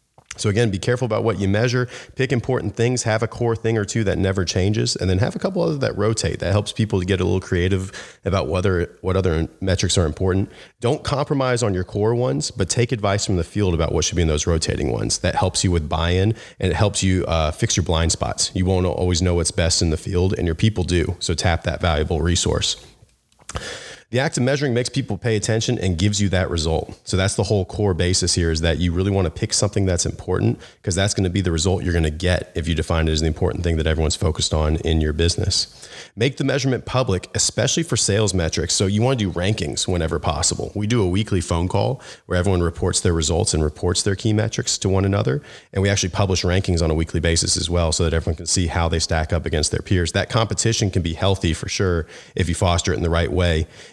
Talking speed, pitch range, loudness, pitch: 245 wpm, 85-110 Hz, -20 LUFS, 95 Hz